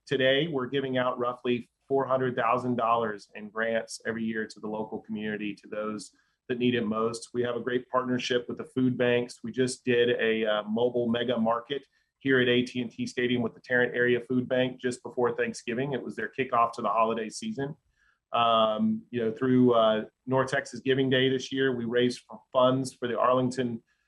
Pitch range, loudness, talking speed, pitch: 115-130 Hz, -28 LUFS, 185 wpm, 120 Hz